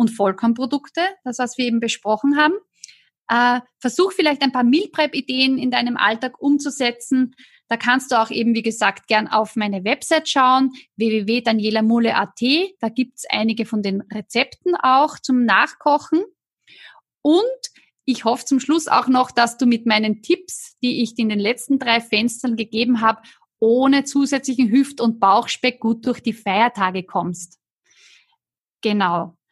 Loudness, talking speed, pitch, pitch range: -19 LUFS, 150 wpm, 245 Hz, 225-275 Hz